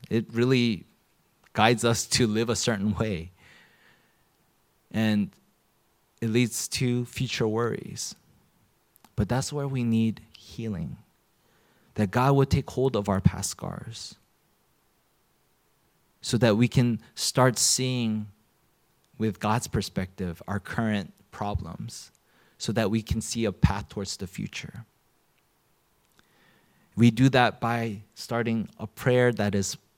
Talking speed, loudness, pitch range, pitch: 120 wpm, -26 LUFS, 105-120 Hz, 115 Hz